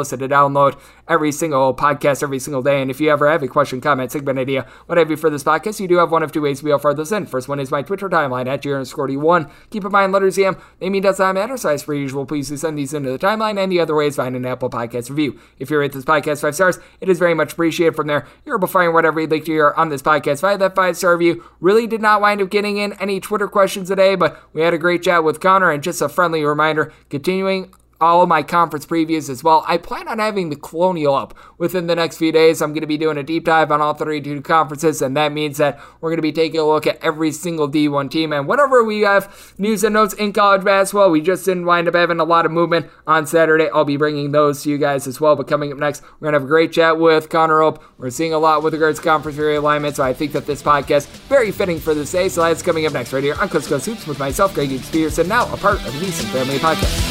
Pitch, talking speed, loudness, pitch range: 155 Hz, 280 wpm, -17 LUFS, 145-175 Hz